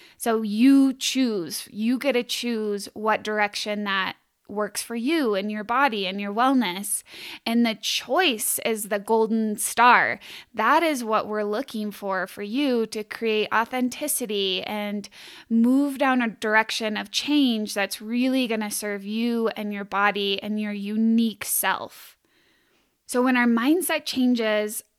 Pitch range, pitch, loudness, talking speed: 210-250 Hz, 220 Hz, -23 LUFS, 150 wpm